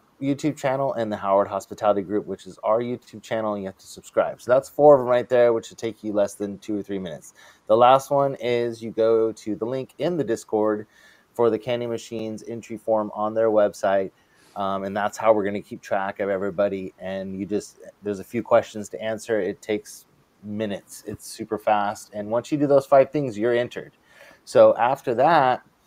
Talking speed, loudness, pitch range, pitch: 215 wpm, -23 LUFS, 100-120 Hz, 110 Hz